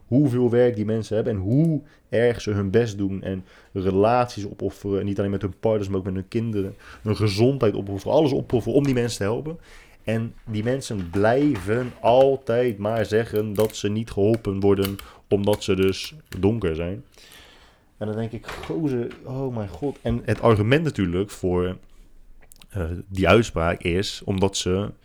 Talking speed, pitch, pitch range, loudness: 175 wpm, 105 Hz, 95-120 Hz, -23 LUFS